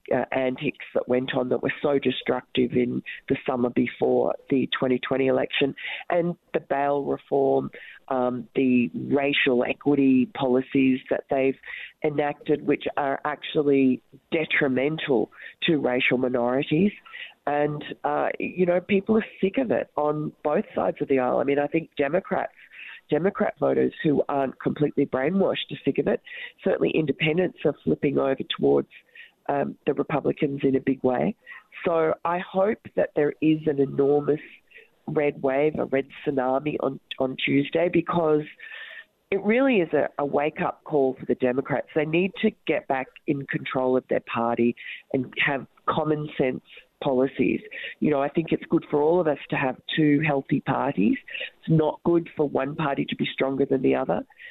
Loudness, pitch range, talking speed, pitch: -25 LUFS, 130-160 Hz, 165 wpm, 145 Hz